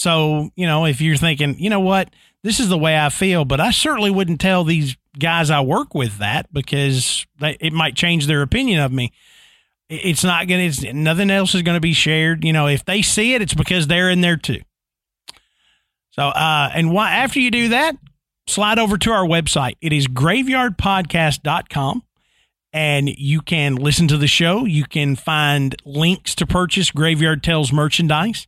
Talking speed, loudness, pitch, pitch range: 190 wpm, -17 LUFS, 160 Hz, 145-185 Hz